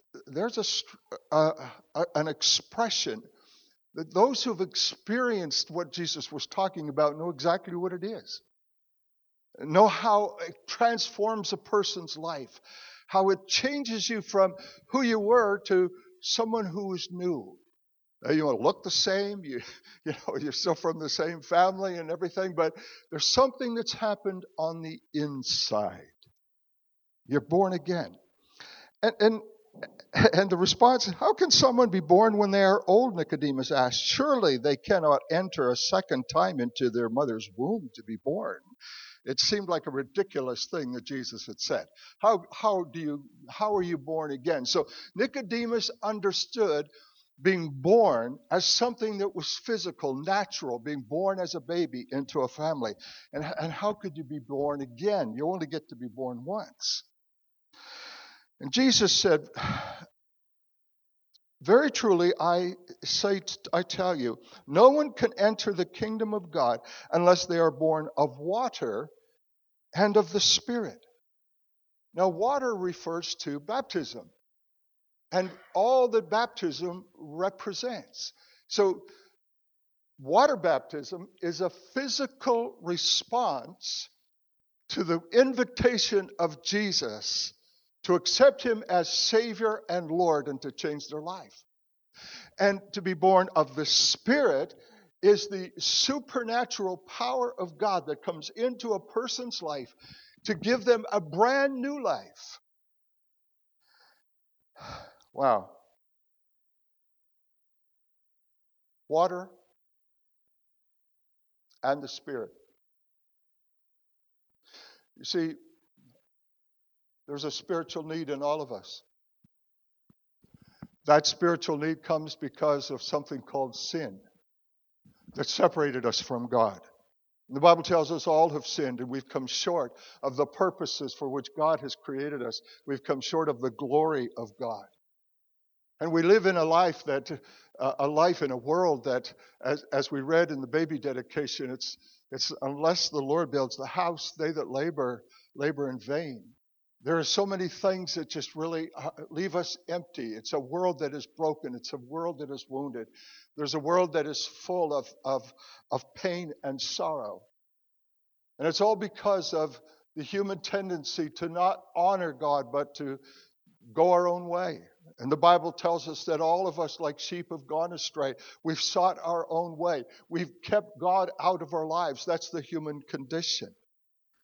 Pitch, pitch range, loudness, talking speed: 175 Hz, 150-210 Hz, -28 LUFS, 145 wpm